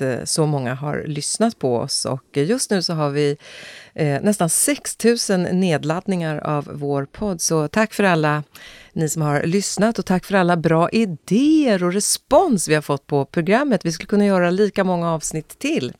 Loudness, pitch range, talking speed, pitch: -19 LUFS, 150-205 Hz, 175 wpm, 175 Hz